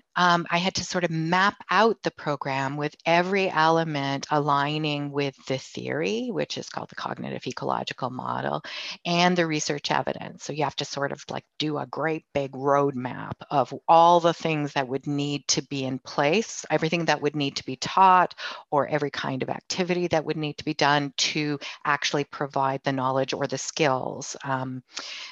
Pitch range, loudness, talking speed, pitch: 140-165 Hz, -25 LUFS, 185 wpm, 150 Hz